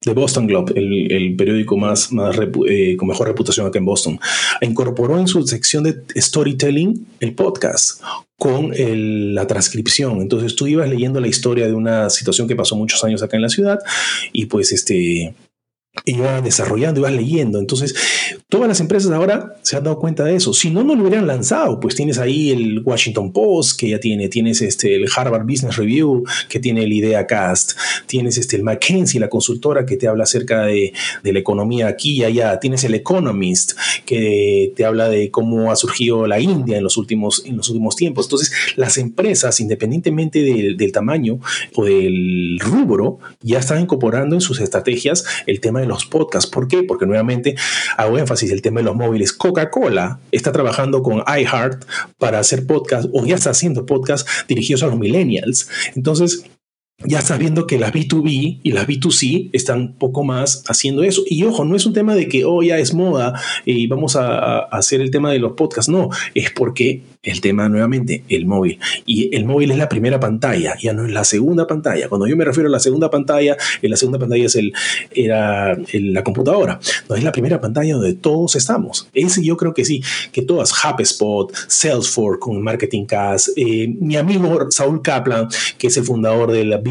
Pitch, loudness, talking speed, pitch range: 130 Hz, -16 LUFS, 195 wpm, 110-155 Hz